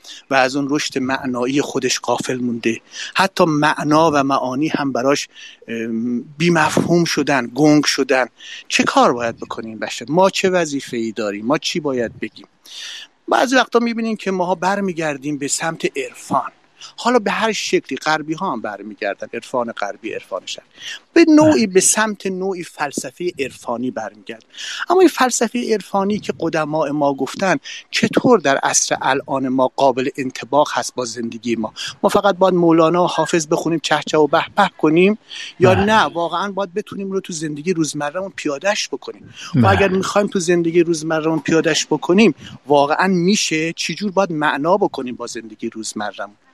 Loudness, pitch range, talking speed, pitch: -18 LUFS, 135-195 Hz, 155 wpm, 160 Hz